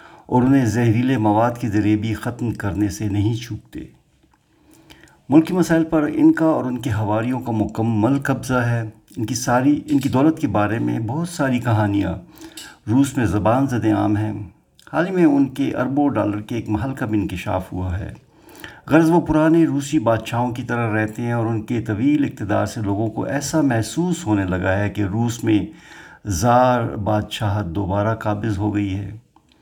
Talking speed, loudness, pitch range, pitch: 180 wpm, -20 LUFS, 105-140 Hz, 115 Hz